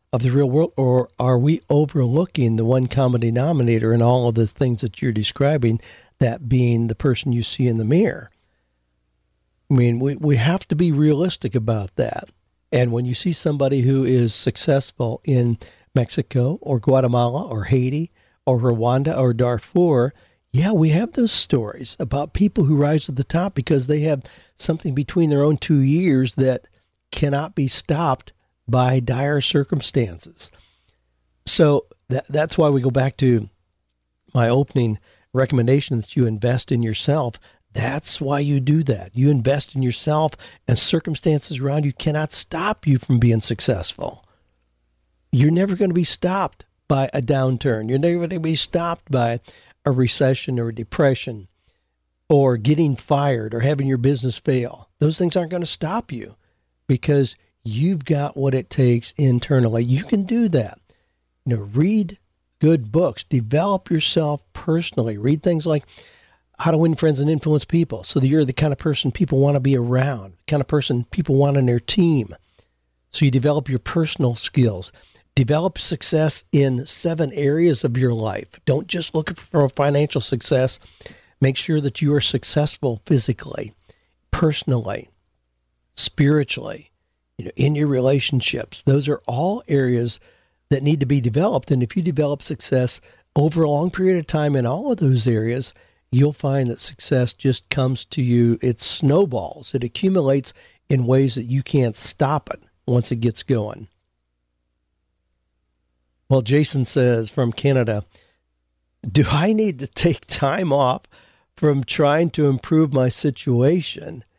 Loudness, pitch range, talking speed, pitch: -20 LUFS, 120-150 Hz, 160 wpm, 135 Hz